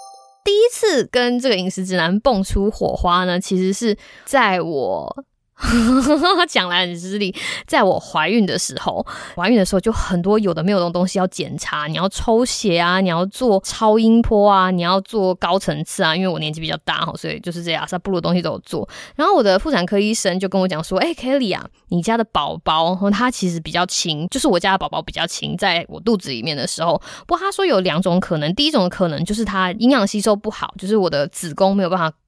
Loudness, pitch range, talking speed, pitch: -18 LUFS, 180-230 Hz, 335 characters per minute, 190 Hz